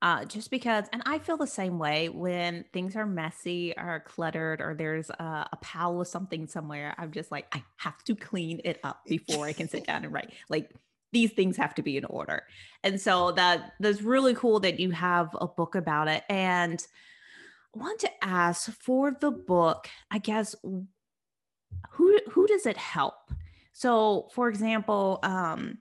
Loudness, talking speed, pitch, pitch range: -29 LUFS, 185 wpm, 180 Hz, 160-220 Hz